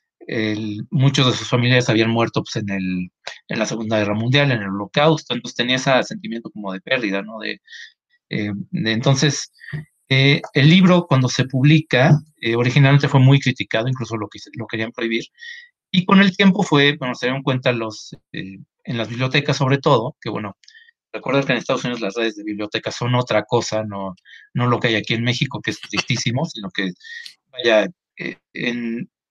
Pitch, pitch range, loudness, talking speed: 125 Hz, 110-145 Hz, -19 LUFS, 190 wpm